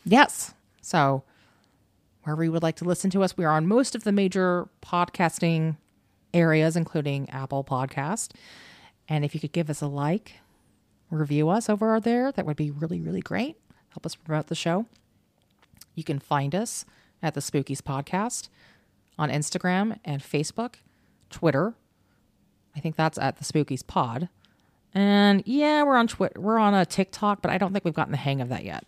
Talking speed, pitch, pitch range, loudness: 175 wpm, 165 Hz, 145-195 Hz, -26 LUFS